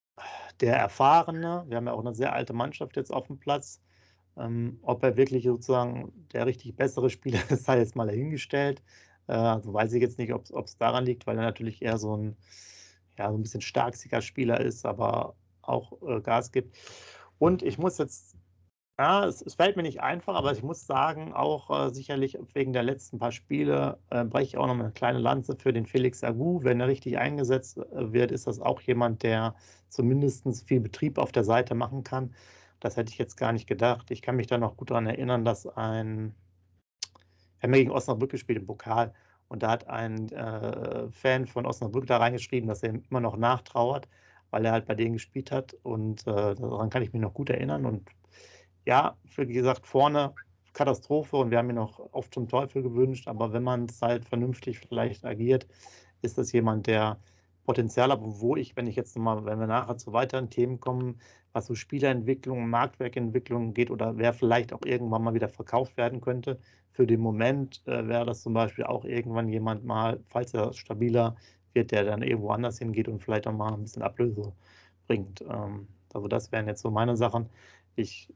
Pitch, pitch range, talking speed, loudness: 120 Hz, 110-125 Hz, 200 wpm, -29 LUFS